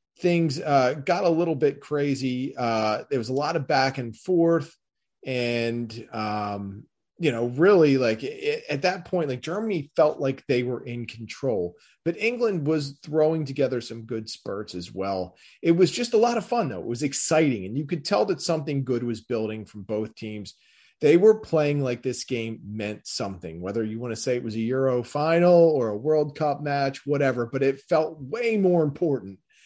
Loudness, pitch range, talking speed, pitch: -25 LUFS, 115-160 Hz, 195 wpm, 135 Hz